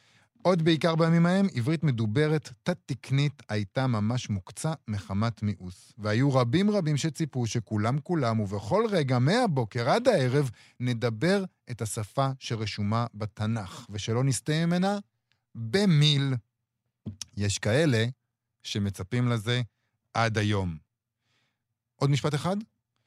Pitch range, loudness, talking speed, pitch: 110-150 Hz, -27 LUFS, 105 wpm, 120 Hz